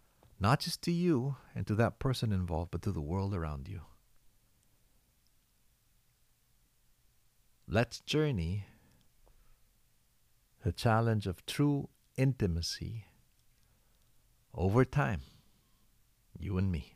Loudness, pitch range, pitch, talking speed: -34 LUFS, 95-130 Hz, 110 Hz, 95 wpm